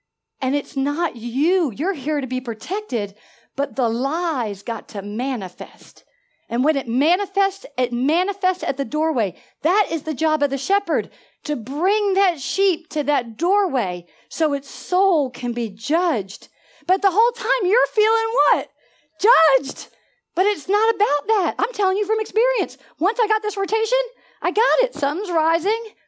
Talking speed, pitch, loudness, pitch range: 165 wpm, 330 Hz, -21 LUFS, 265-400 Hz